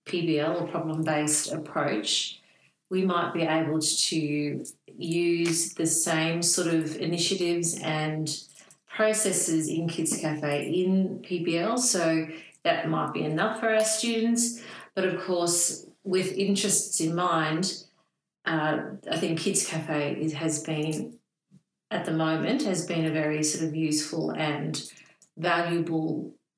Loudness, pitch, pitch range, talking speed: -26 LUFS, 165 Hz, 160-185 Hz, 130 wpm